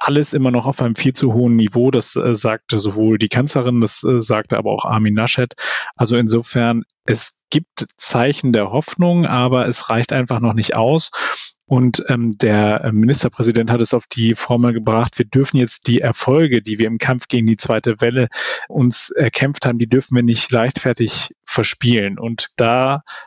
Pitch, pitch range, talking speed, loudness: 120 Hz, 115-130 Hz, 180 wpm, -16 LUFS